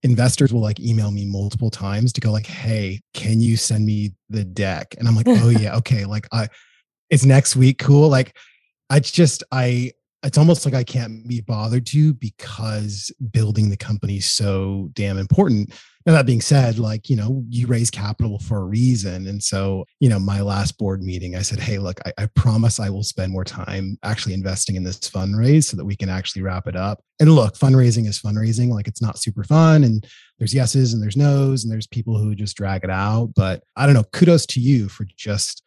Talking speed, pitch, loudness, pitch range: 215 wpm, 110 Hz, -19 LUFS, 100-125 Hz